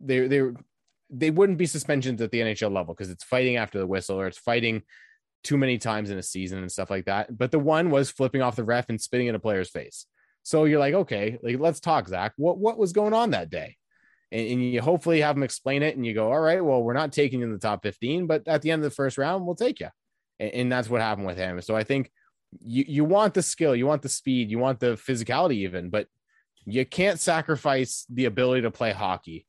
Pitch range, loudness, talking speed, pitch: 110-150 Hz, -25 LUFS, 250 wpm, 125 Hz